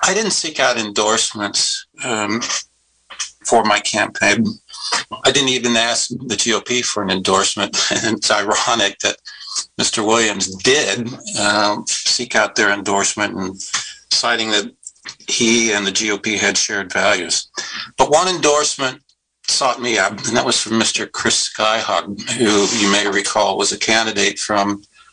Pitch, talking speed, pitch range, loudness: 110 Hz, 145 wpm, 100-120 Hz, -16 LUFS